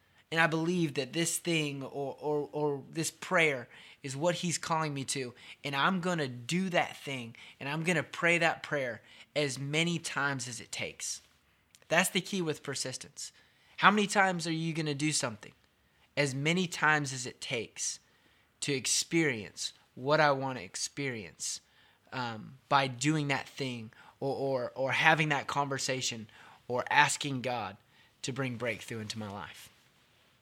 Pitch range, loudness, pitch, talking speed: 125-160 Hz, -31 LUFS, 140 Hz, 165 wpm